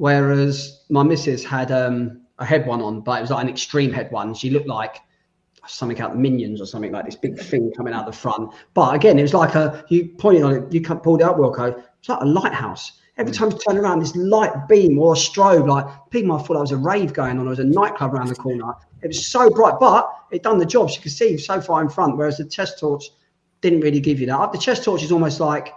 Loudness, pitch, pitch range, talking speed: -19 LUFS, 145 Hz, 125-170 Hz, 265 wpm